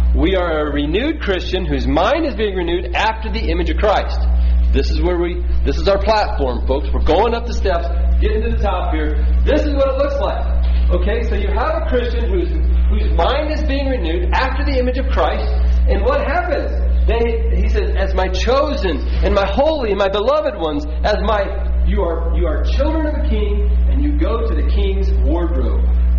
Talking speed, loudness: 205 wpm, -17 LUFS